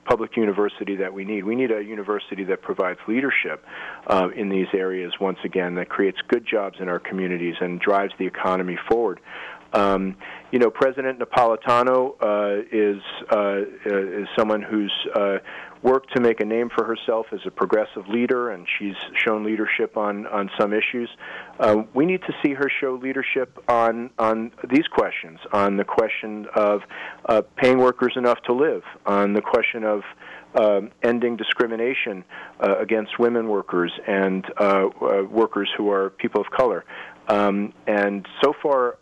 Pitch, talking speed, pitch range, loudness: 105 Hz, 165 wpm, 100-120 Hz, -22 LUFS